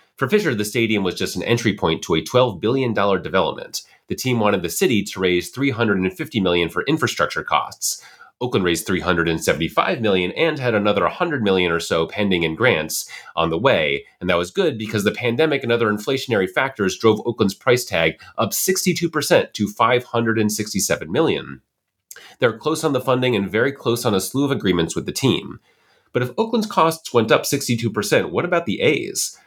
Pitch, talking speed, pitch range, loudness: 110 Hz, 185 wpm, 95-130 Hz, -20 LUFS